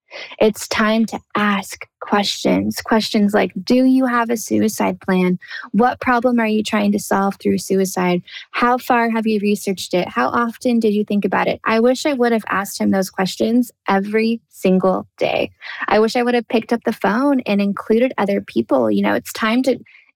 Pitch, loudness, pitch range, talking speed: 215 Hz, -18 LUFS, 195-235 Hz, 195 wpm